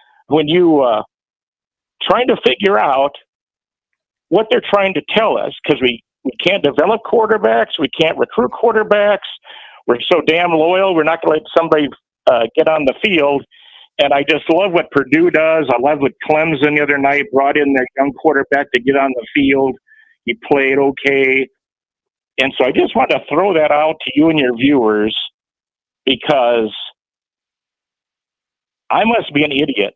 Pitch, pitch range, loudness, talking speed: 150 Hz, 140-160 Hz, -14 LUFS, 170 wpm